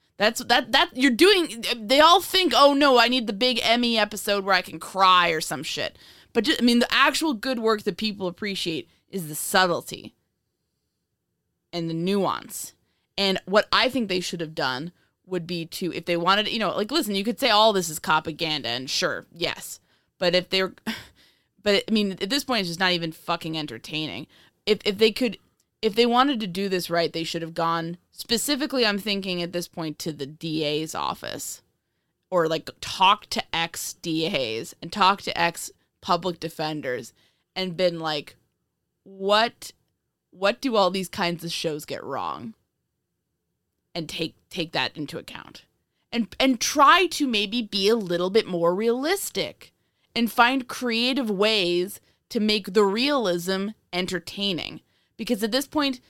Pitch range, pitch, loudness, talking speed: 170-235 Hz, 195 Hz, -23 LUFS, 175 wpm